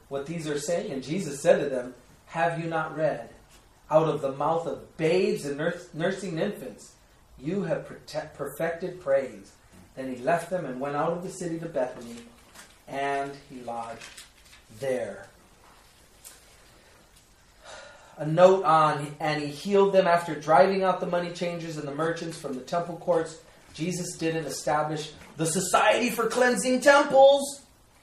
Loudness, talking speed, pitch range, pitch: -26 LUFS, 150 wpm, 140-175 Hz, 160 Hz